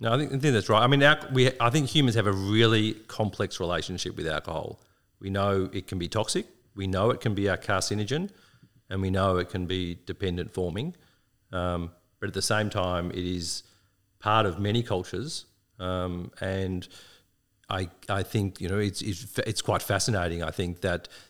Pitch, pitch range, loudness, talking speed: 100 Hz, 90-115 Hz, -28 LUFS, 195 wpm